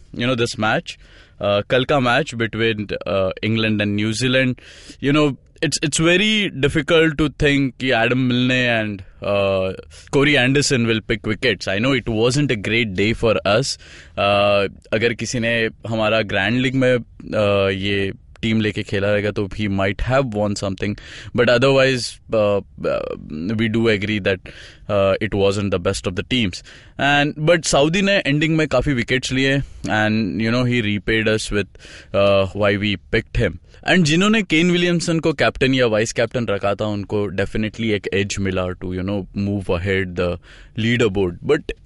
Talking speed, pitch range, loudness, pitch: 160 wpm, 100-130 Hz, -19 LUFS, 110 Hz